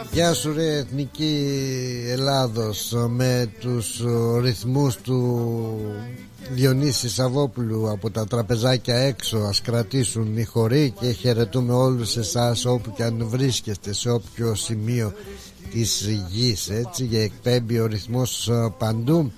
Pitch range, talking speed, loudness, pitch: 115-130 Hz, 115 wpm, -23 LUFS, 120 Hz